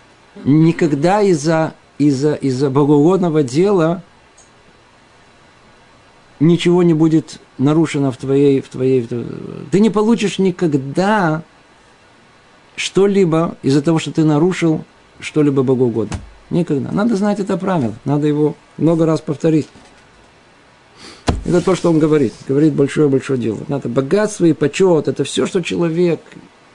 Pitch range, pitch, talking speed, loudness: 140-175 Hz, 155 Hz, 120 wpm, -15 LUFS